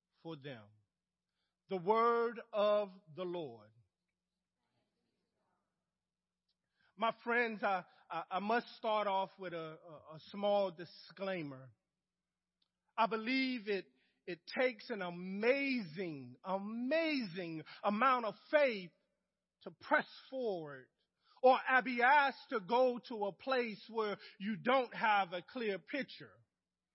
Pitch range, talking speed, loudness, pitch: 180-235 Hz, 105 wpm, -36 LUFS, 200 Hz